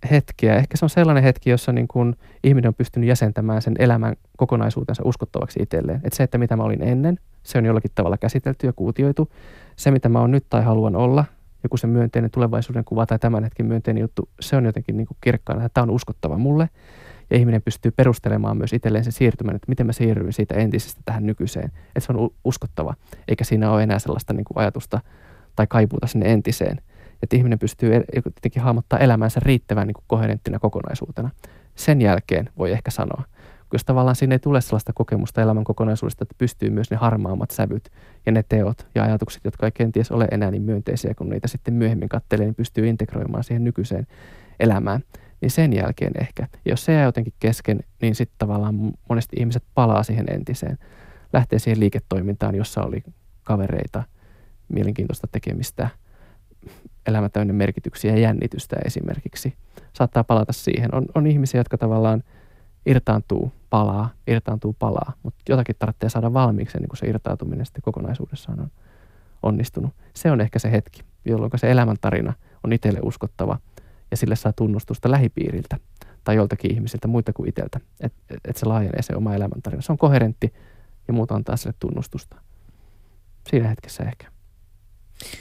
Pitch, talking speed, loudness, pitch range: 115 Hz, 170 wpm, -21 LUFS, 105-125 Hz